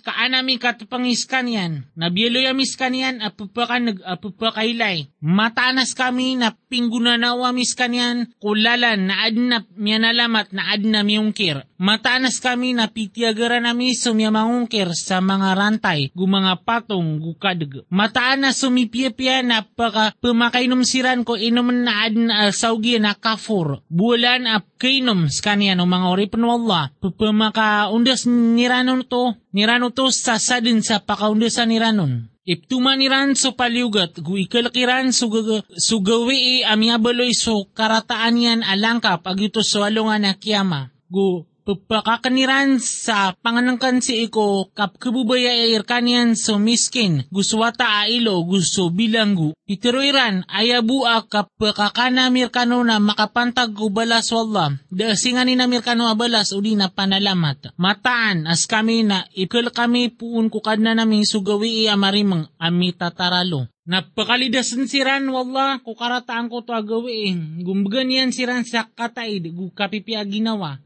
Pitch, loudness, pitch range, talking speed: 225 Hz, -18 LUFS, 200-245 Hz, 125 wpm